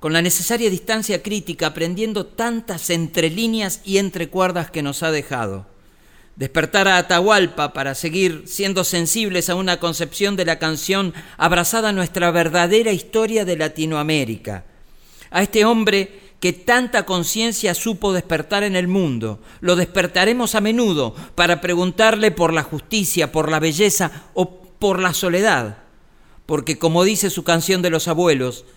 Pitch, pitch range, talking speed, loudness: 180 Hz, 160-200 Hz, 150 wpm, -18 LUFS